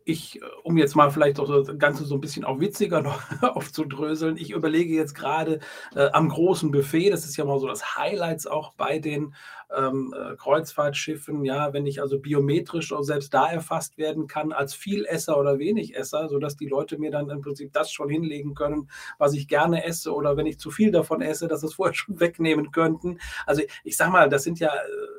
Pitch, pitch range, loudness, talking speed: 150 Hz, 145-160 Hz, -25 LUFS, 205 wpm